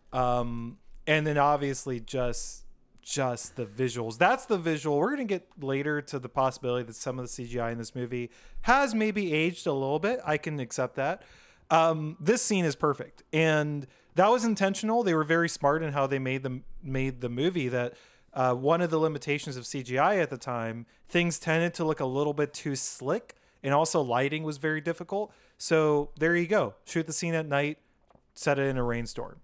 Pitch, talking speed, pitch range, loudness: 145 Hz, 200 wpm, 130-165 Hz, -28 LUFS